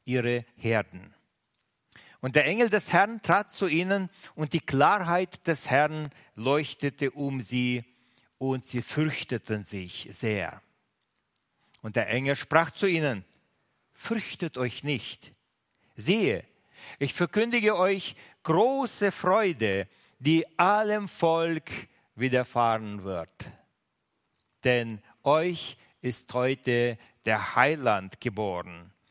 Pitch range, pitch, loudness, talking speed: 120-170 Hz, 135 Hz, -27 LUFS, 105 wpm